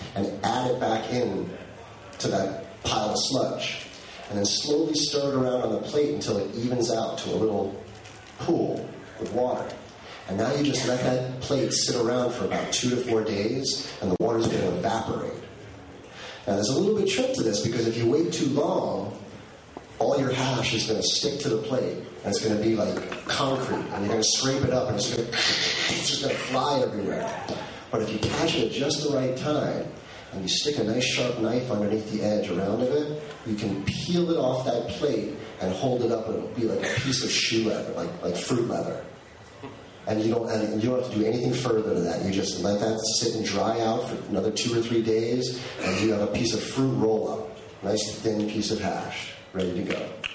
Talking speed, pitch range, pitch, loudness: 220 wpm, 105-125 Hz, 115 Hz, -26 LUFS